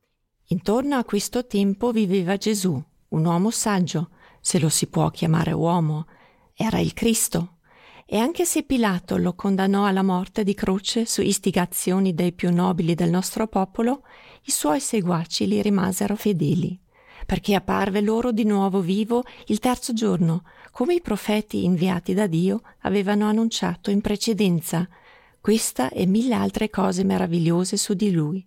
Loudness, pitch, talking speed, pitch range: -22 LUFS, 195 Hz, 150 wpm, 180-215 Hz